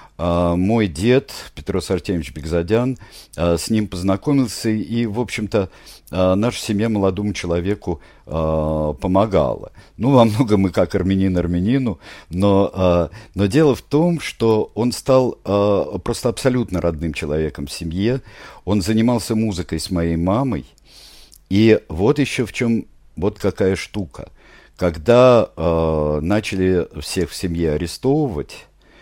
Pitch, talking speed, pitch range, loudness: 100 Hz, 130 wpm, 85-115 Hz, -19 LUFS